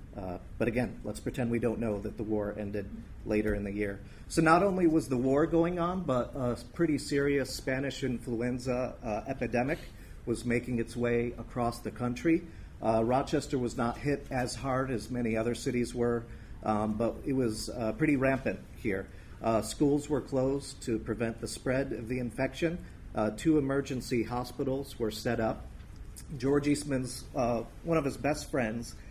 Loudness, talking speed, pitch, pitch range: -32 LUFS, 175 wpm, 120 Hz, 110-135 Hz